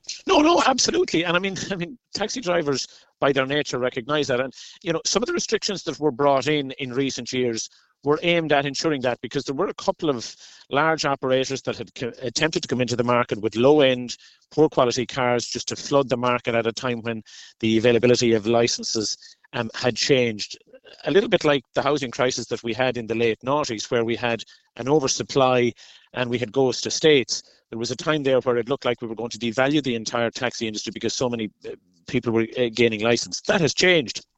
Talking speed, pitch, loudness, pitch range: 220 wpm, 125 Hz, -22 LUFS, 120-150 Hz